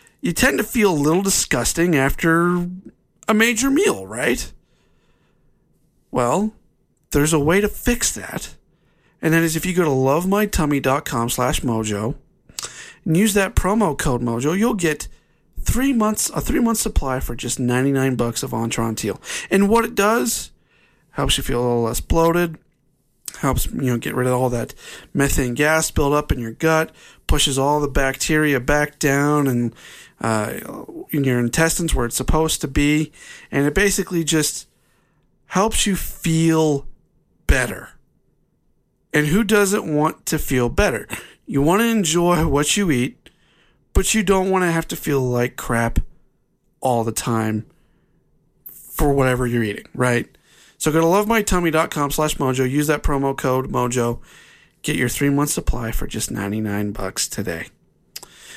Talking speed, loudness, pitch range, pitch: 155 wpm, -19 LUFS, 125-175 Hz, 150 Hz